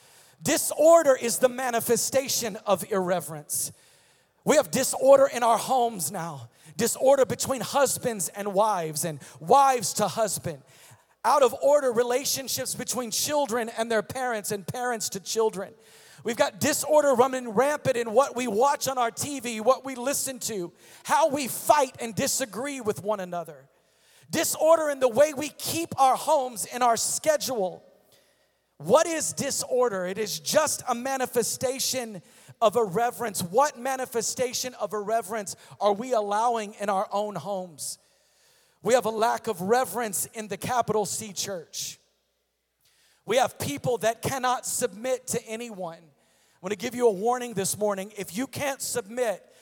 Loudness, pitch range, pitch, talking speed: -25 LUFS, 205-260 Hz, 235 Hz, 150 wpm